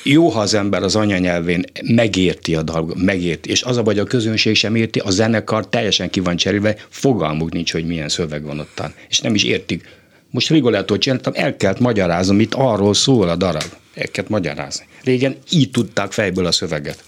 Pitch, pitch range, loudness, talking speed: 100 Hz, 90-115 Hz, -17 LUFS, 185 wpm